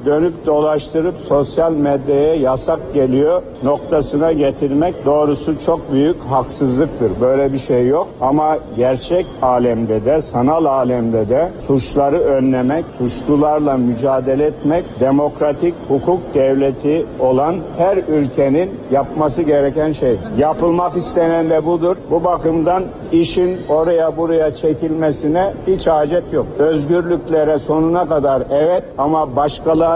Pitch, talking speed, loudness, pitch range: 150 Hz, 110 wpm, -15 LUFS, 135-165 Hz